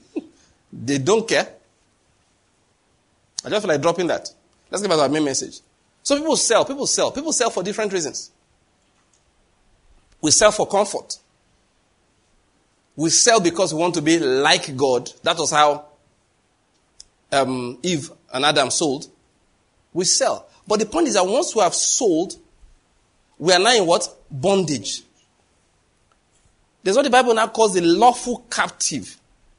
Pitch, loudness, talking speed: 180 Hz, -19 LUFS, 145 wpm